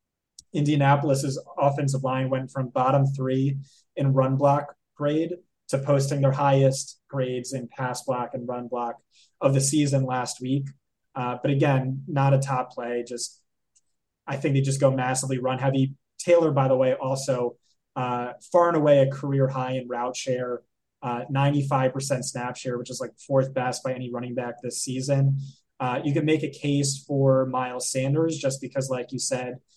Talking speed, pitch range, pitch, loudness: 175 wpm, 125-140 Hz, 135 Hz, -25 LUFS